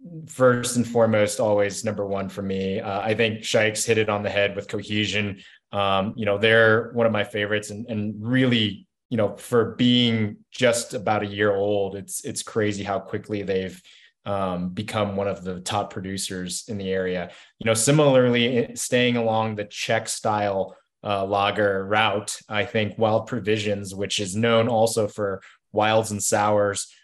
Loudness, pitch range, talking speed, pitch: -23 LUFS, 100-110 Hz, 175 wpm, 105 Hz